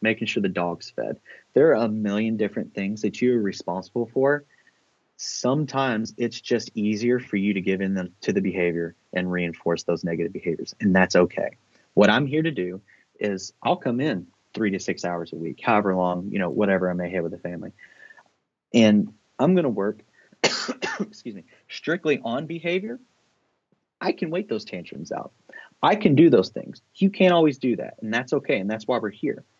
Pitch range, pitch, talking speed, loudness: 90-120 Hz, 105 Hz, 195 wpm, -24 LUFS